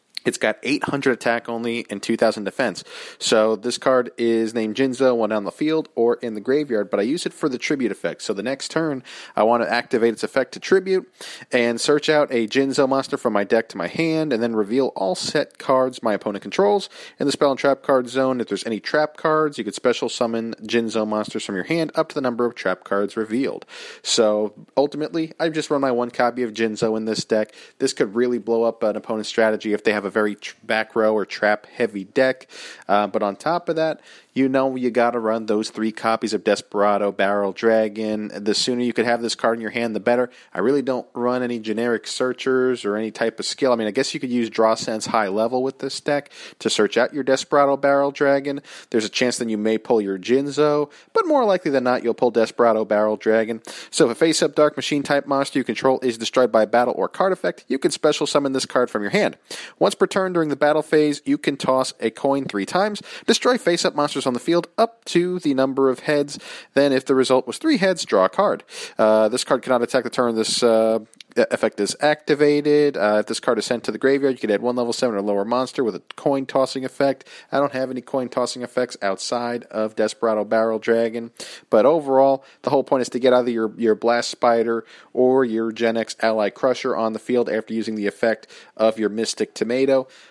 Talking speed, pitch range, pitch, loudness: 230 wpm, 110-140 Hz, 125 Hz, -21 LUFS